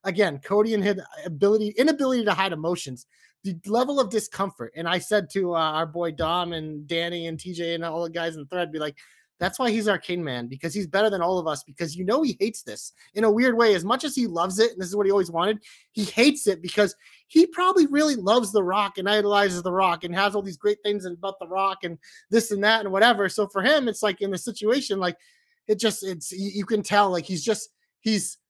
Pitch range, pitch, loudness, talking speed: 175-220 Hz, 200 Hz, -24 LUFS, 250 wpm